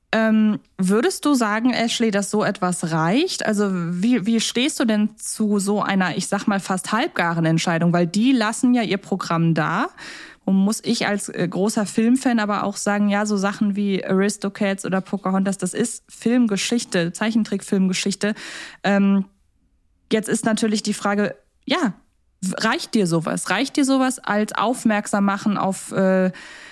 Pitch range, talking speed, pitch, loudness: 195-230 Hz, 155 wpm, 205 Hz, -21 LUFS